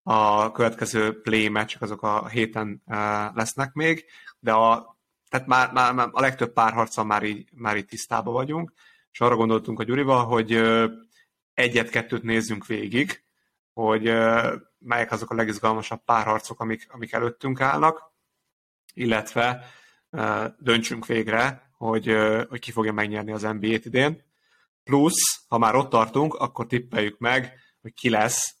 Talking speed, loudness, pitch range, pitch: 135 wpm, -23 LUFS, 110-125 Hz, 115 Hz